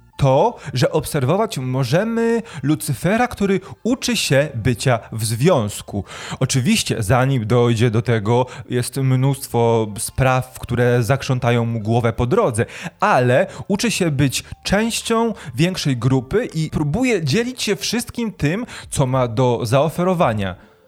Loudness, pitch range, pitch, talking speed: -19 LUFS, 120-180 Hz, 135 Hz, 120 wpm